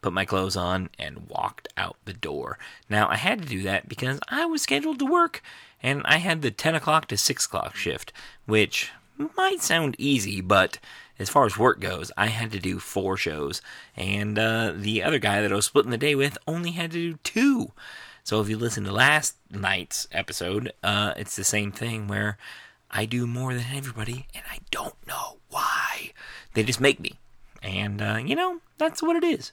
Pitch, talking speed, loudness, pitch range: 115 Hz, 205 wpm, -25 LUFS, 100-155 Hz